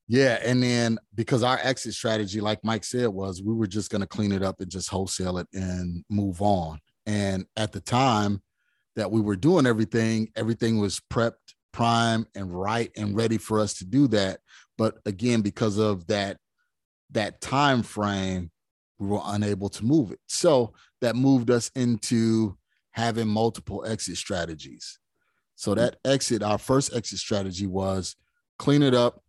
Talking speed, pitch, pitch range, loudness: 170 wpm, 110 Hz, 100-115 Hz, -26 LUFS